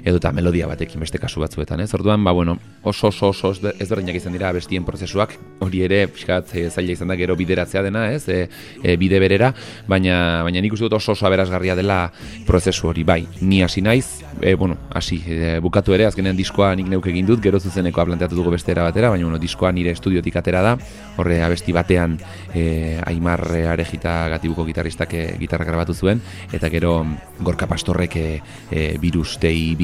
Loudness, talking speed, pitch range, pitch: -19 LUFS, 190 wpm, 85-95 Hz, 90 Hz